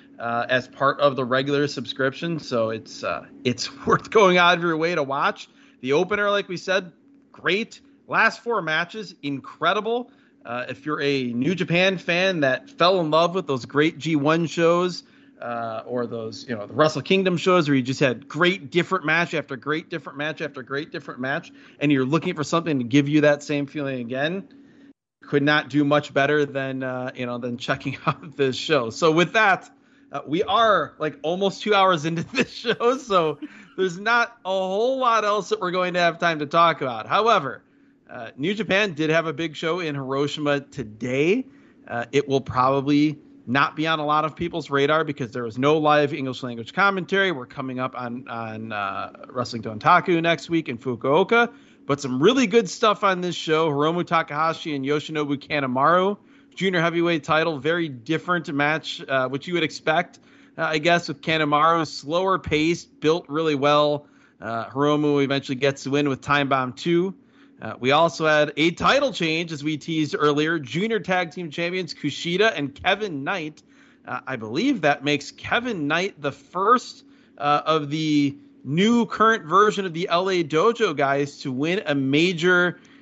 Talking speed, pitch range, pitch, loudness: 185 wpm, 140-185 Hz, 155 Hz, -22 LUFS